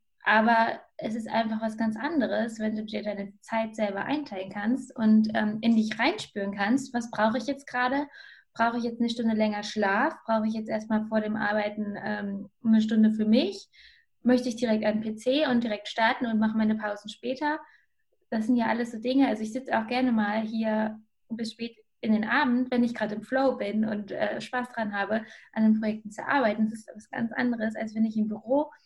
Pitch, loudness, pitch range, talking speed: 225 Hz, -27 LUFS, 215-250 Hz, 210 wpm